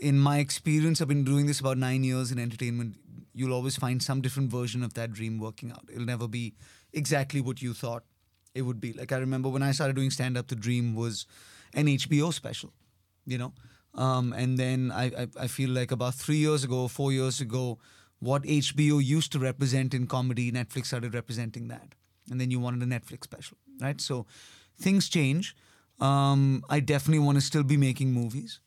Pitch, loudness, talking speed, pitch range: 130 Hz, -29 LUFS, 200 wpm, 120-140 Hz